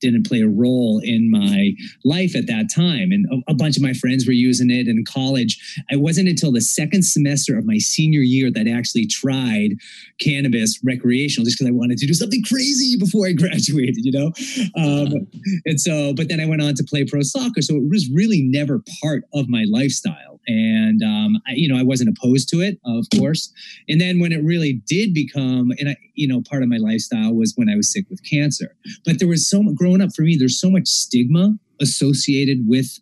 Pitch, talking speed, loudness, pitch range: 155 Hz, 220 wpm, -18 LUFS, 130-205 Hz